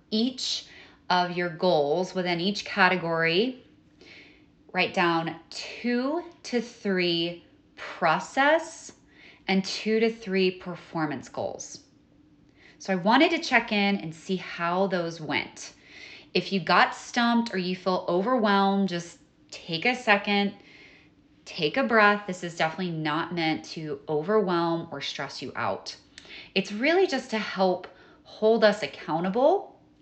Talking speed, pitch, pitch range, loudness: 130 wpm, 190 Hz, 170-225 Hz, -26 LUFS